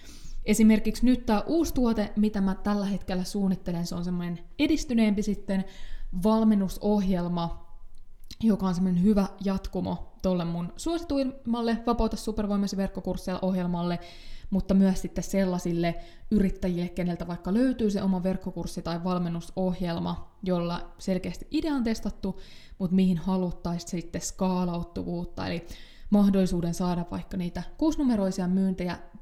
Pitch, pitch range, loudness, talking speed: 190 Hz, 175-210 Hz, -28 LUFS, 120 wpm